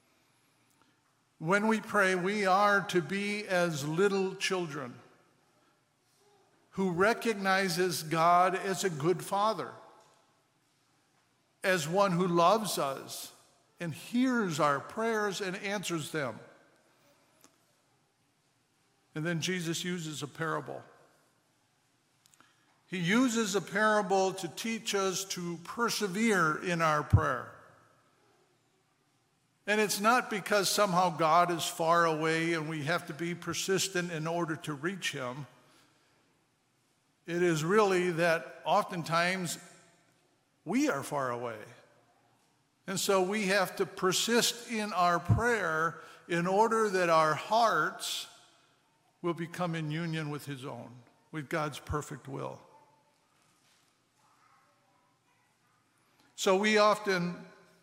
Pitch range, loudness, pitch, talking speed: 155-195 Hz, -30 LUFS, 175 Hz, 110 wpm